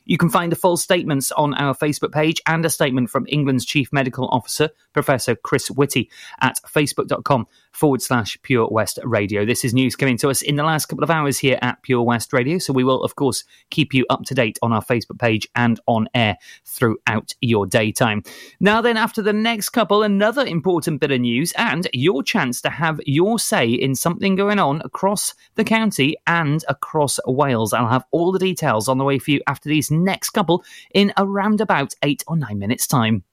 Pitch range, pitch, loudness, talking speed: 125-170 Hz, 145 Hz, -19 LUFS, 205 wpm